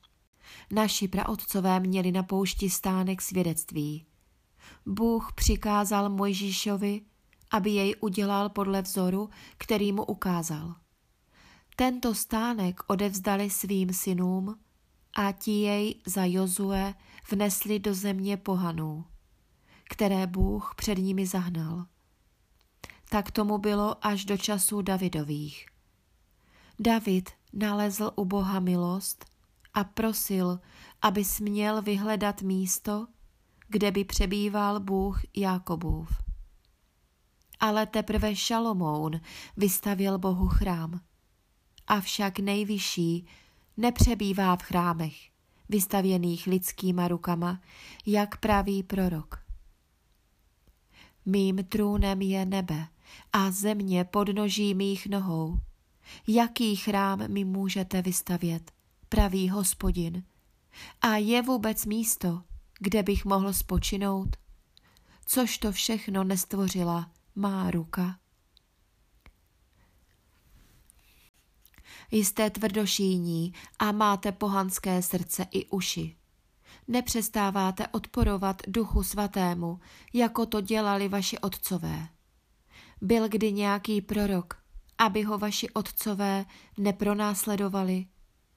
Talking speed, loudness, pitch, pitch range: 90 wpm, -29 LUFS, 195 Hz, 180-210 Hz